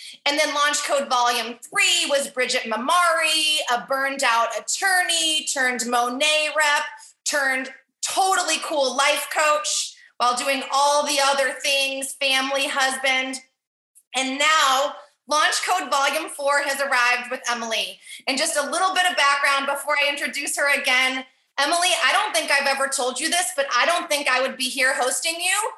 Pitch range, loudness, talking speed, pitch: 260-305 Hz, -20 LUFS, 165 wpm, 280 Hz